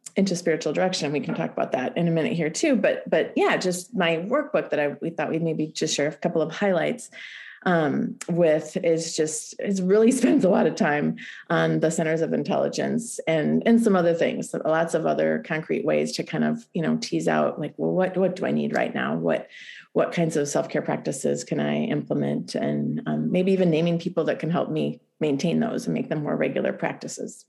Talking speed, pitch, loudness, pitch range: 220 wpm, 165 Hz, -24 LUFS, 145-185 Hz